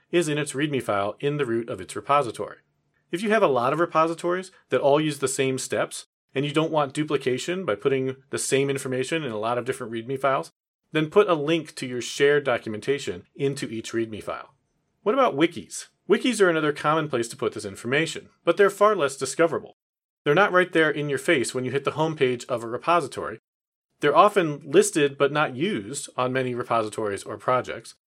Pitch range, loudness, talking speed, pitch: 130-160 Hz, -24 LUFS, 205 wpm, 145 Hz